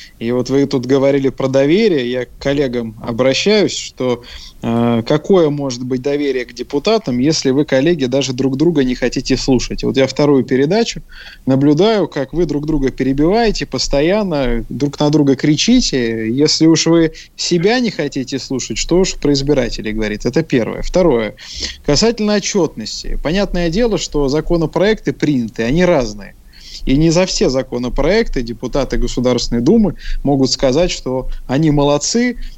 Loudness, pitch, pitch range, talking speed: -15 LUFS, 140 Hz, 130-165 Hz, 145 wpm